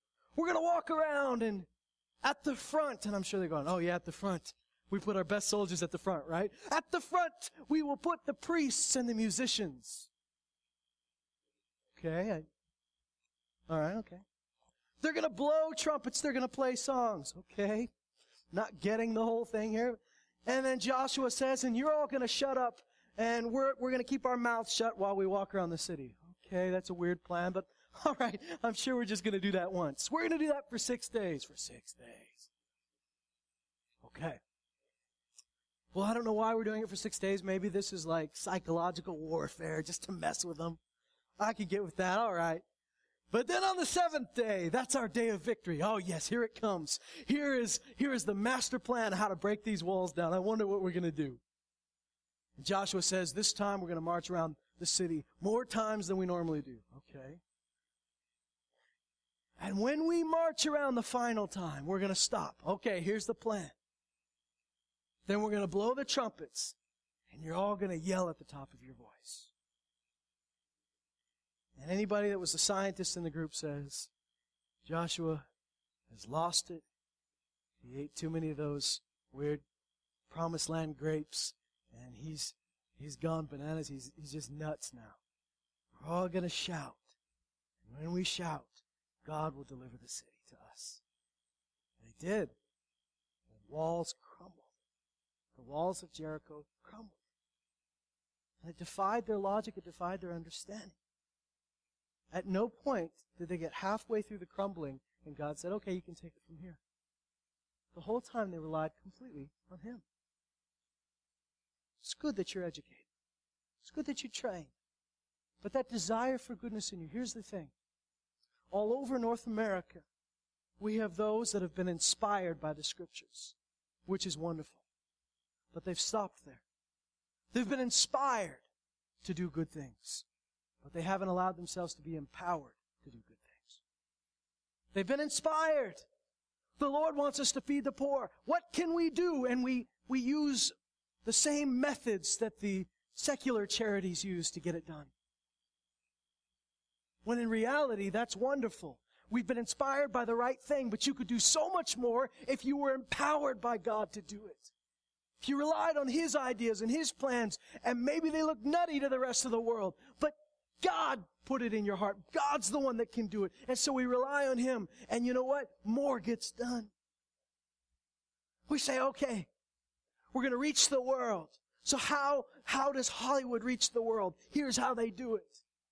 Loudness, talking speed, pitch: -36 LUFS, 175 wpm, 185 Hz